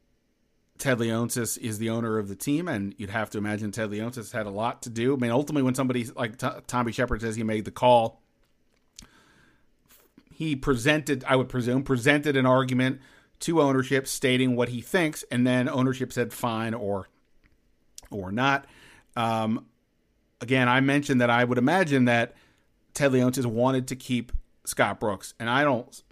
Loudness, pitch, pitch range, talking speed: -26 LUFS, 125 Hz, 115-130 Hz, 170 wpm